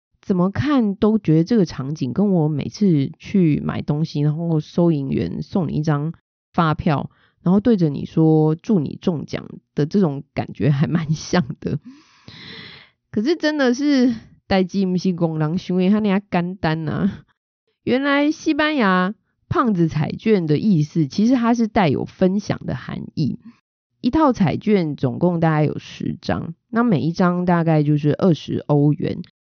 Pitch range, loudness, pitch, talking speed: 155-210 Hz, -20 LUFS, 180 Hz, 230 characters per minute